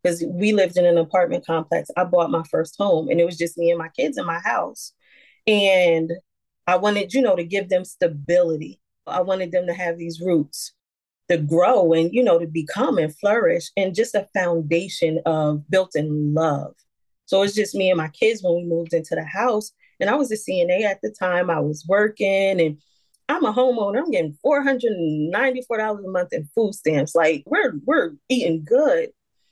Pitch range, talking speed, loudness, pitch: 165-205 Hz, 200 wpm, -21 LUFS, 180 Hz